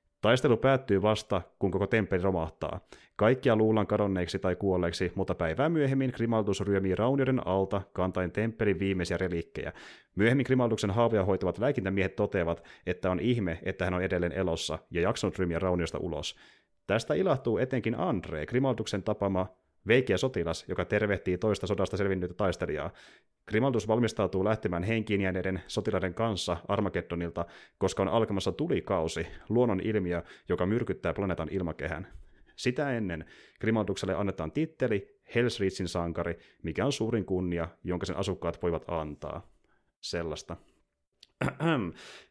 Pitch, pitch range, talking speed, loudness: 95 Hz, 90-110 Hz, 130 wpm, -30 LUFS